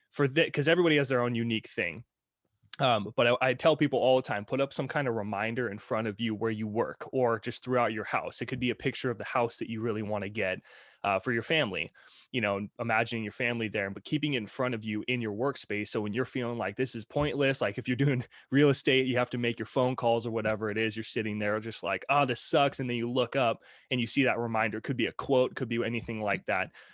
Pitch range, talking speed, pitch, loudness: 110-130 Hz, 275 wpm, 120 Hz, -30 LUFS